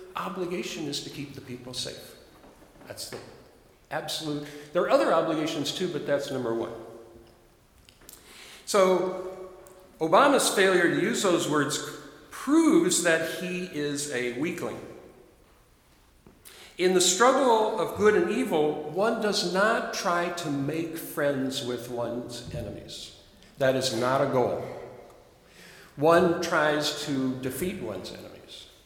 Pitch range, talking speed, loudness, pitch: 140-185 Hz, 125 wpm, -26 LUFS, 155 Hz